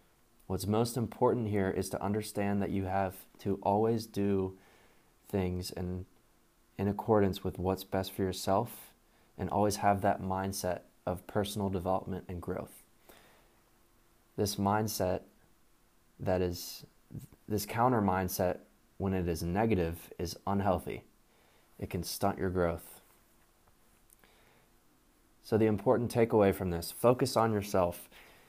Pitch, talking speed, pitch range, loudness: 95 Hz, 125 wpm, 90-105 Hz, -33 LUFS